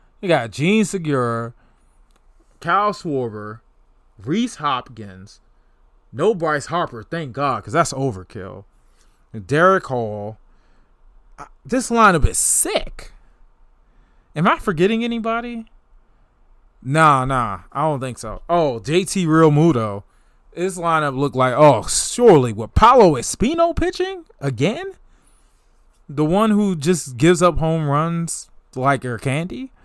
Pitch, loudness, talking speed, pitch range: 145 Hz, -18 LUFS, 120 wpm, 115-185 Hz